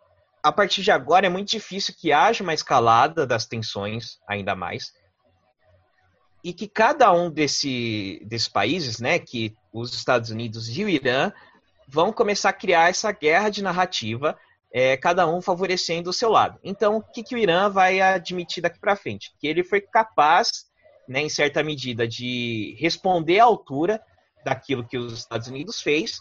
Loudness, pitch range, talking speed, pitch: -22 LUFS, 120-190 Hz, 170 wpm, 160 Hz